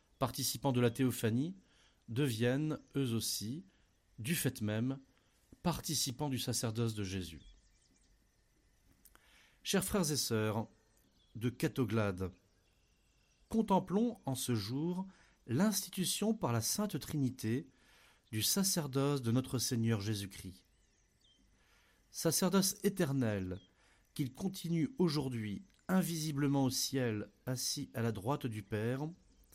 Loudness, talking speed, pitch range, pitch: -36 LUFS, 100 wpm, 110-155 Hz, 125 Hz